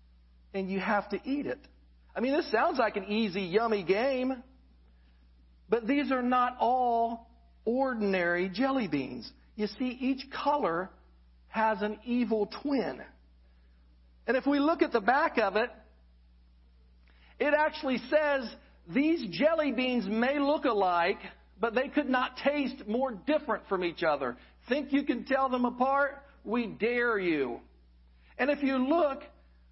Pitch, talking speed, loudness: 230 Hz, 145 wpm, -30 LUFS